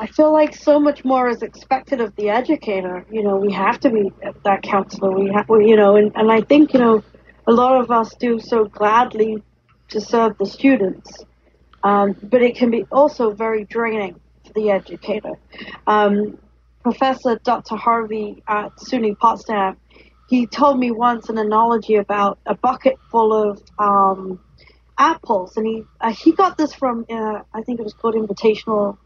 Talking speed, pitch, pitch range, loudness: 175 wpm, 220 Hz, 210-245 Hz, -18 LUFS